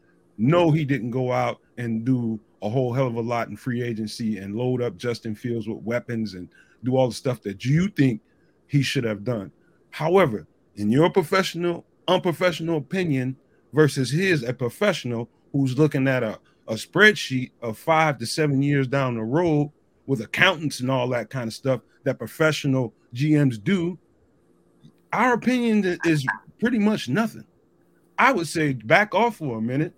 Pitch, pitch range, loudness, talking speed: 135 Hz, 120-165 Hz, -23 LUFS, 170 wpm